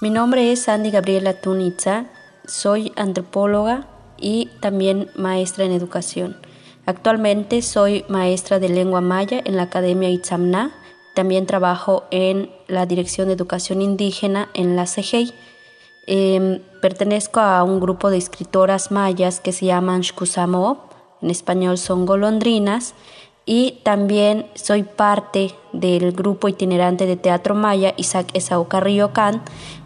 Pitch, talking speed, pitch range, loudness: 190 Hz, 130 wpm, 185-205 Hz, -19 LUFS